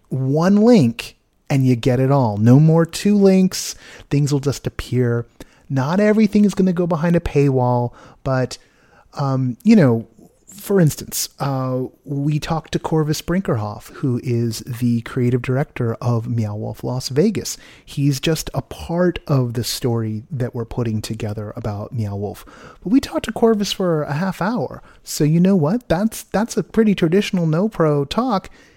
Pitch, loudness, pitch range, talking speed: 140 Hz, -19 LUFS, 120-180 Hz, 170 wpm